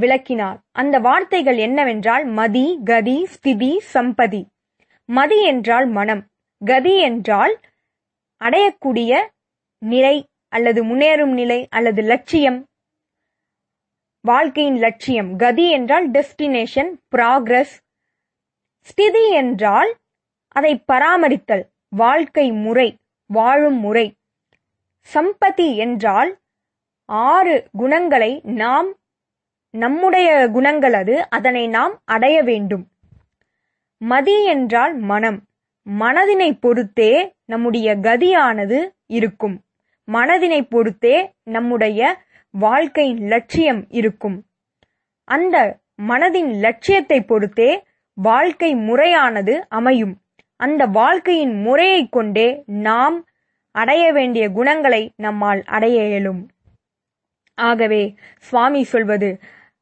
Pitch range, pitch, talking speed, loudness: 225-300 Hz, 250 Hz, 80 wpm, -16 LUFS